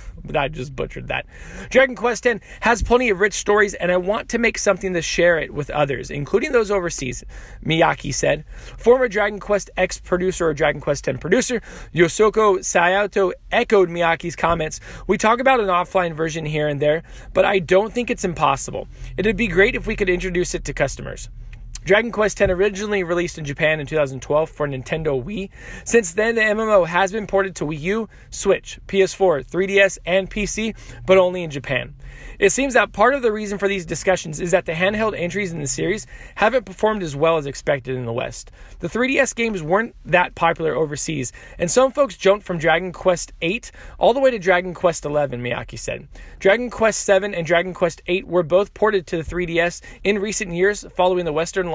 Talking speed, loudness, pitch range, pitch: 195 wpm, -20 LUFS, 160-205 Hz, 185 Hz